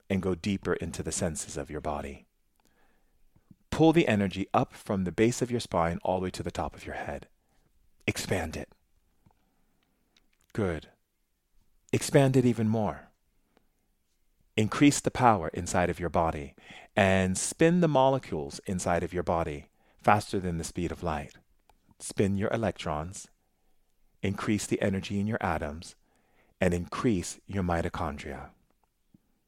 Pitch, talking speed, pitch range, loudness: 95 Hz, 140 wpm, 85-105 Hz, -29 LUFS